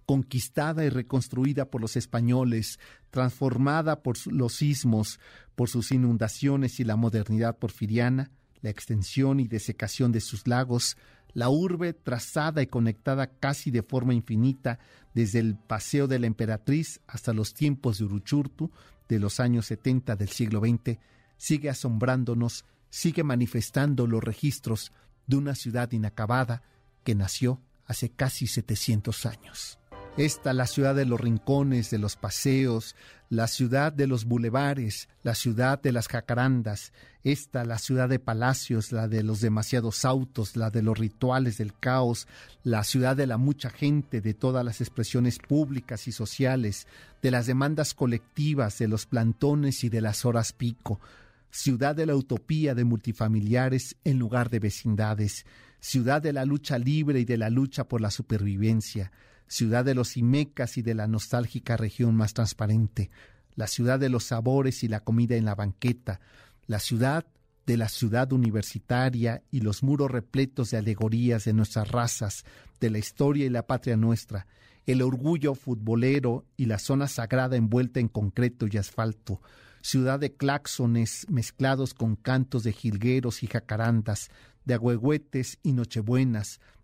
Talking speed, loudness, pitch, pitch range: 150 wpm, -27 LUFS, 120 Hz, 110-130 Hz